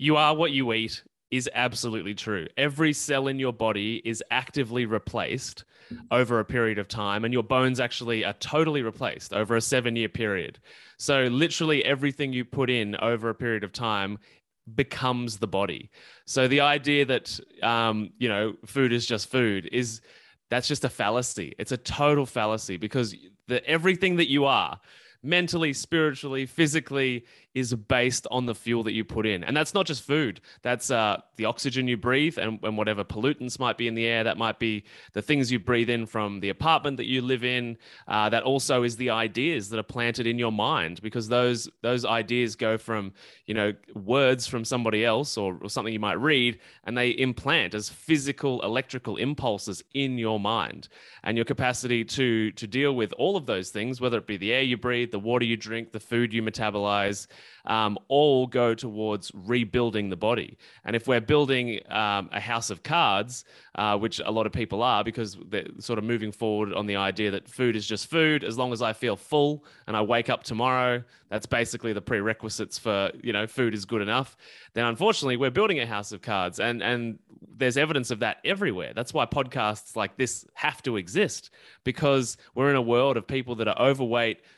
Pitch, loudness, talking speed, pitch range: 120 Hz, -26 LUFS, 195 wpm, 110-130 Hz